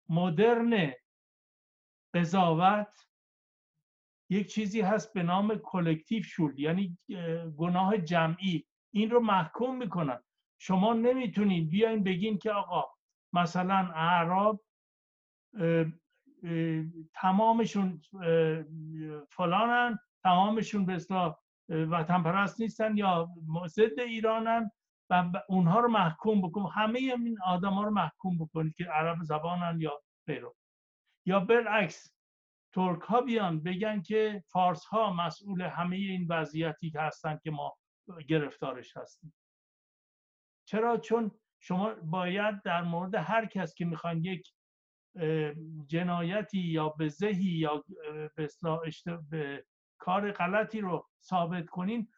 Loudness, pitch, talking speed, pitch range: -31 LUFS, 180 Hz, 110 wpm, 165-210 Hz